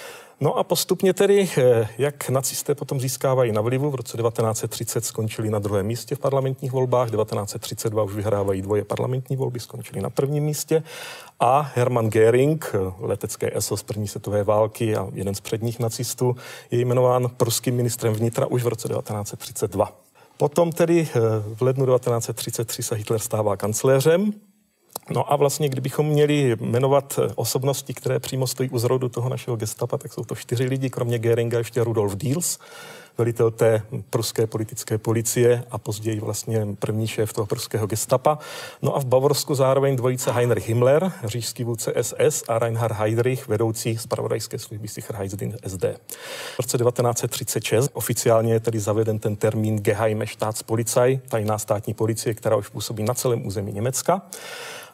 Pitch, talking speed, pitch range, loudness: 120 Hz, 155 wpm, 110-135 Hz, -23 LUFS